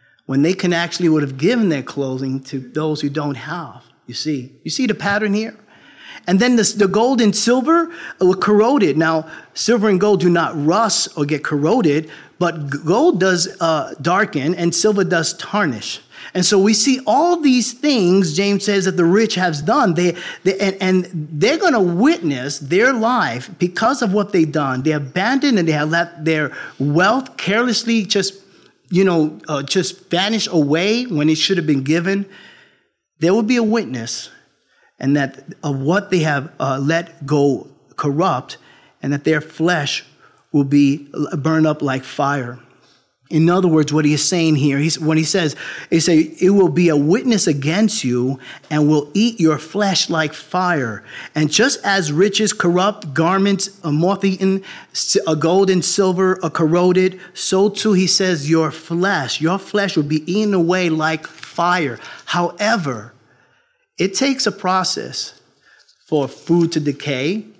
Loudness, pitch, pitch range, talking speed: -17 LUFS, 175 Hz, 150-200 Hz, 170 wpm